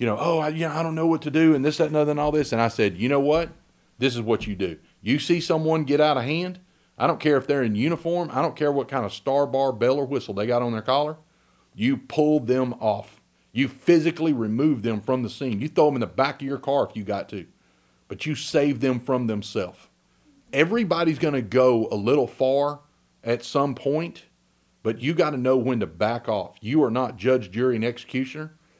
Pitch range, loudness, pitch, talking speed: 120-155 Hz, -23 LUFS, 140 Hz, 245 wpm